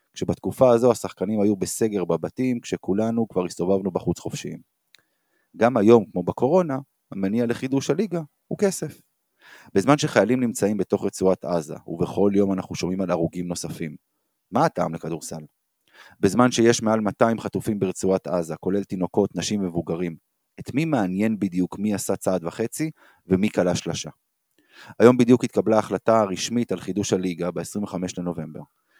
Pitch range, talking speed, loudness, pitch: 90-120 Hz, 140 wpm, -23 LUFS, 100 Hz